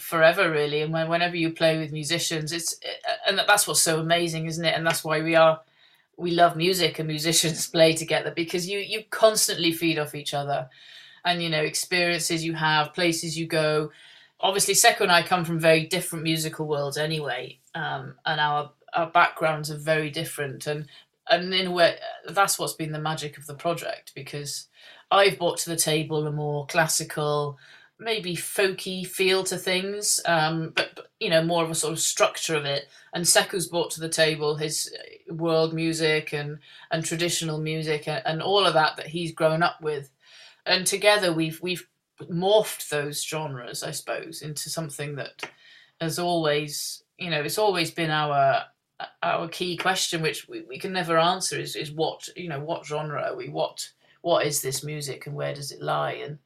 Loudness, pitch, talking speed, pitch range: -24 LUFS, 160 Hz, 190 wpm, 155-175 Hz